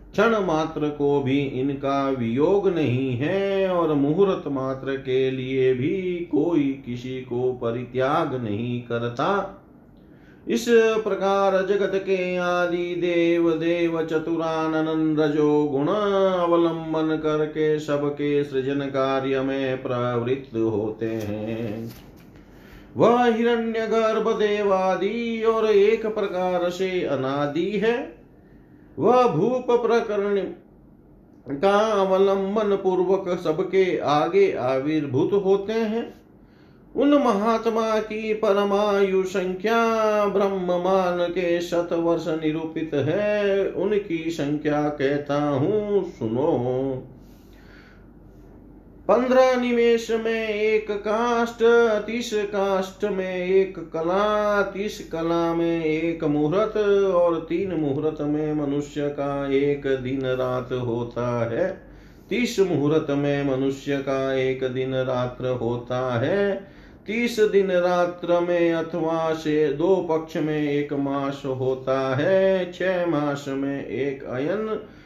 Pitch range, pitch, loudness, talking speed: 140-200 Hz, 170 Hz, -23 LUFS, 105 wpm